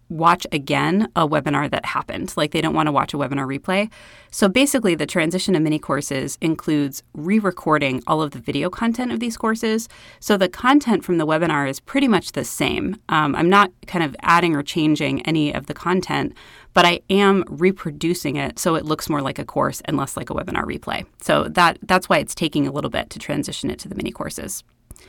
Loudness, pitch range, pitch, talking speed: -20 LUFS, 150-195 Hz, 170 Hz, 215 wpm